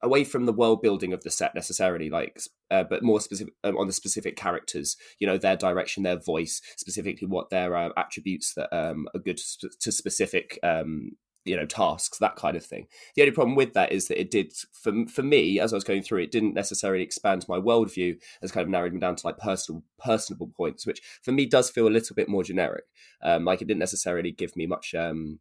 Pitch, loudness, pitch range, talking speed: 95 Hz, -27 LUFS, 85-115 Hz, 230 wpm